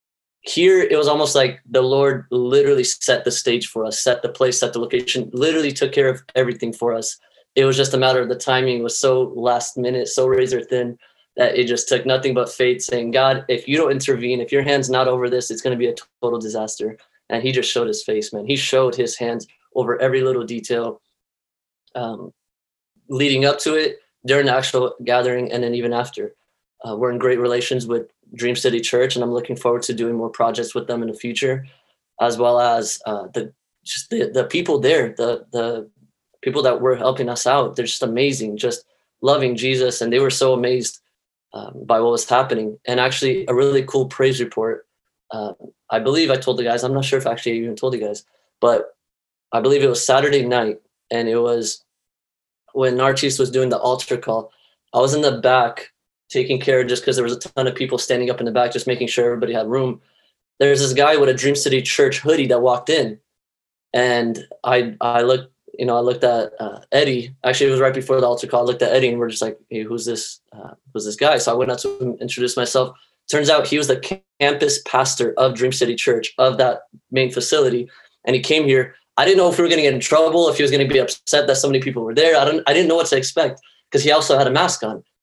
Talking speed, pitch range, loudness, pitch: 235 wpm, 120-140 Hz, -18 LUFS, 125 Hz